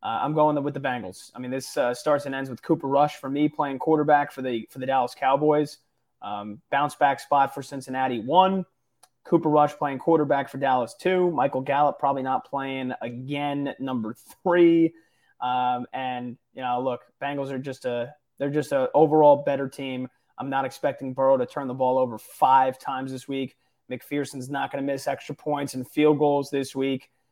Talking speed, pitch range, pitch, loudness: 195 wpm, 130-145 Hz, 135 Hz, -25 LUFS